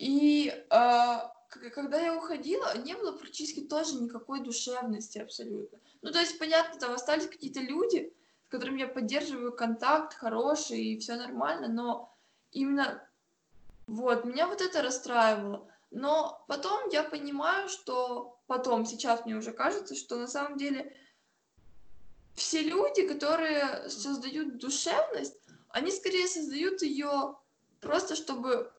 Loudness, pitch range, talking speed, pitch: -31 LUFS, 245-320 Hz, 125 wpm, 280 Hz